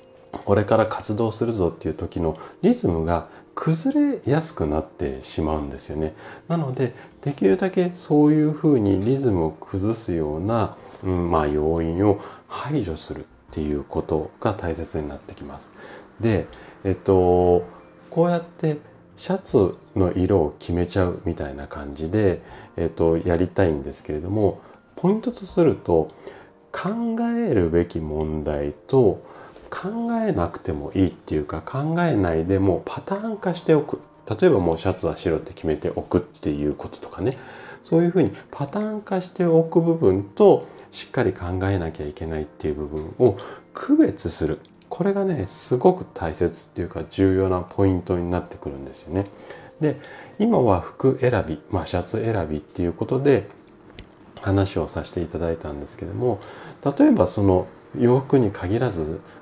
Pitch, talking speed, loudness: 95 Hz, 330 characters per minute, -23 LUFS